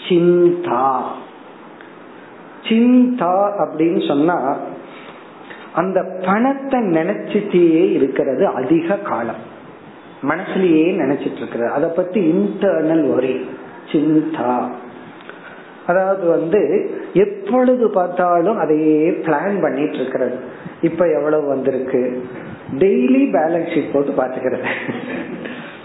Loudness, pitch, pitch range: -17 LUFS, 170 Hz, 150-200 Hz